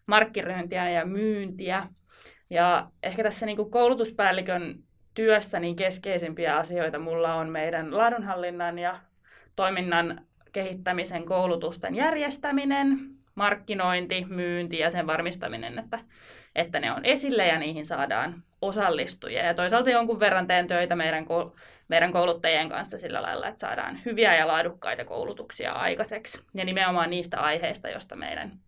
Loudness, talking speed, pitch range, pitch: -27 LUFS, 130 wpm, 170-220 Hz, 185 Hz